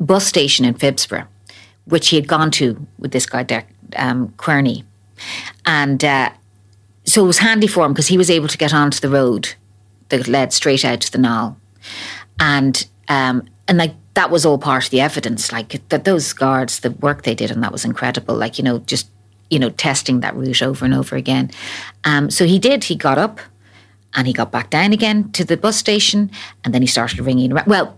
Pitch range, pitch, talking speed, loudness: 115-155 Hz, 130 Hz, 210 wpm, -16 LUFS